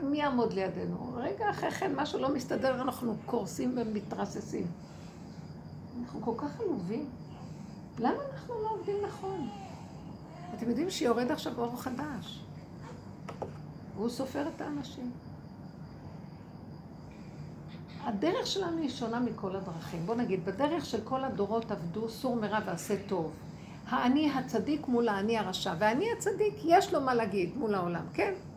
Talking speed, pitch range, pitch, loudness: 130 wpm, 195-270 Hz, 235 Hz, -33 LUFS